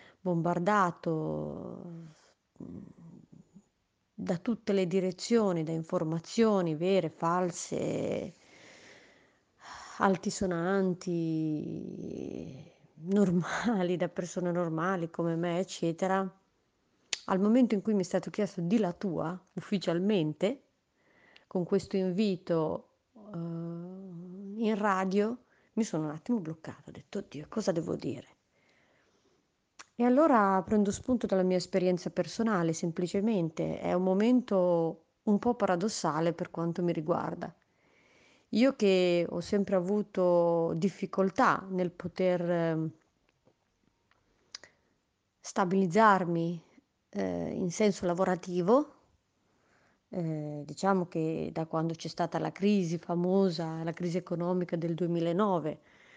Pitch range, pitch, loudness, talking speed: 170-200 Hz, 180 Hz, -31 LUFS, 100 wpm